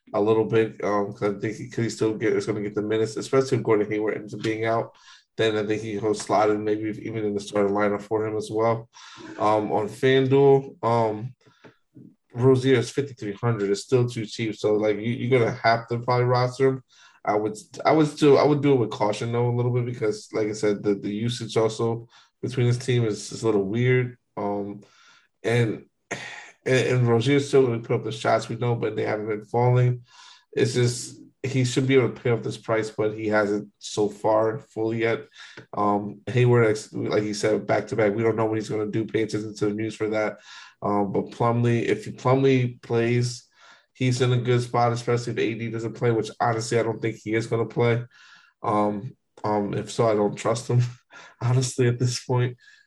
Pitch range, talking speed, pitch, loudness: 105-125 Hz, 220 wpm, 115 Hz, -24 LUFS